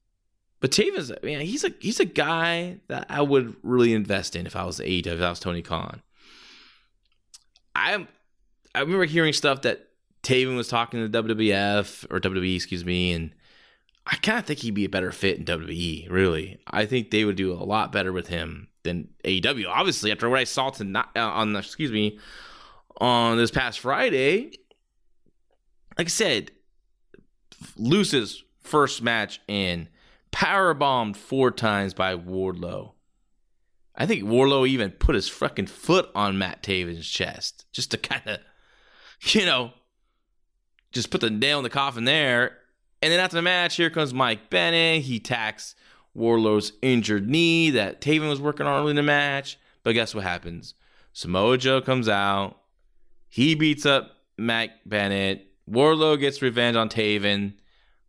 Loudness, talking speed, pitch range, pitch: -24 LUFS, 160 wpm, 100-140 Hz, 115 Hz